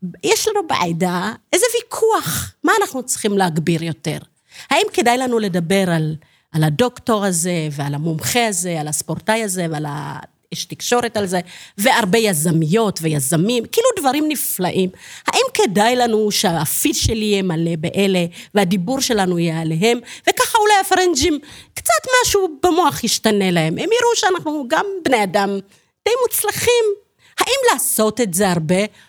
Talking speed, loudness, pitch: 140 wpm, -17 LUFS, 215 Hz